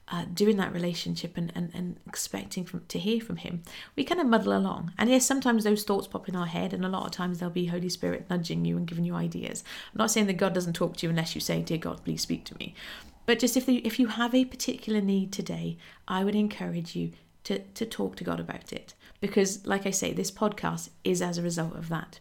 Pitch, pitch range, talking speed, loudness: 185 Hz, 175-215 Hz, 255 wpm, -29 LUFS